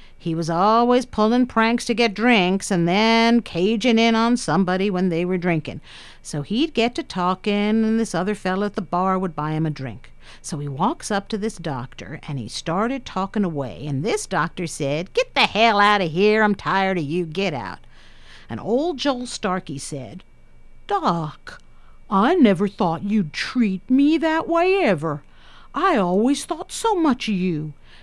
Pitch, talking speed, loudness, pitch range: 195 Hz, 180 wpm, -21 LUFS, 165-230 Hz